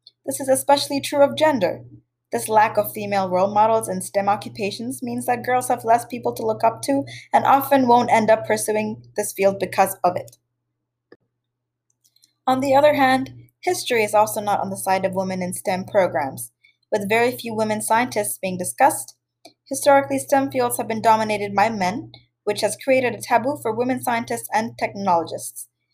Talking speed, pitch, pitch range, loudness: 180 wpm, 215 Hz, 185-250 Hz, -20 LUFS